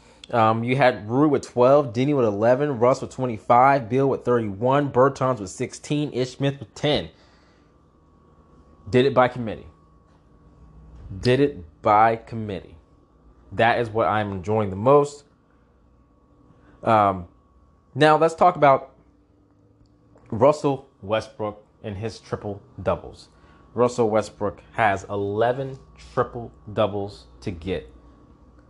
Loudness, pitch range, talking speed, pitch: -22 LUFS, 85-125 Hz, 115 wpm, 110 Hz